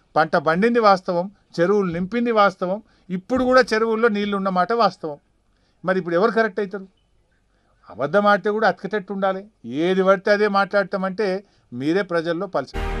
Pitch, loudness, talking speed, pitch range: 195 Hz, -20 LUFS, 135 wpm, 170-205 Hz